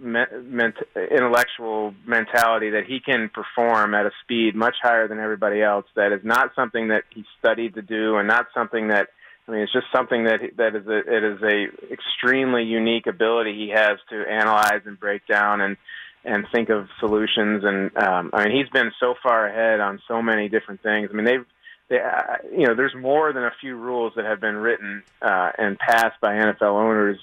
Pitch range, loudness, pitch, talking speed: 105-120 Hz, -21 LUFS, 110 Hz, 205 wpm